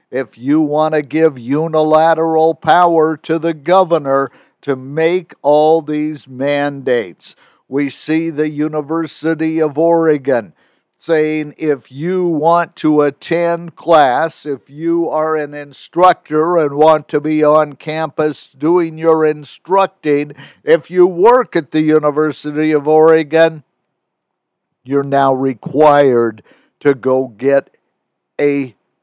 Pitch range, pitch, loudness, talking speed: 145-165 Hz, 155 Hz, -14 LUFS, 120 wpm